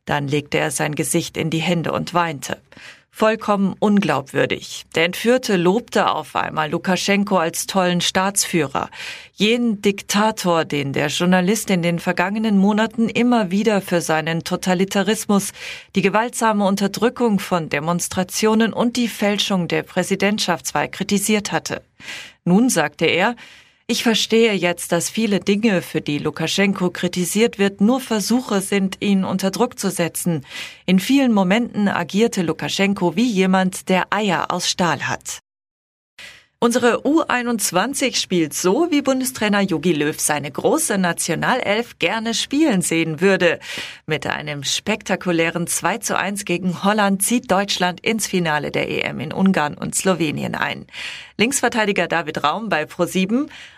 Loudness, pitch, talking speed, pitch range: -19 LUFS, 195 Hz, 135 wpm, 170-220 Hz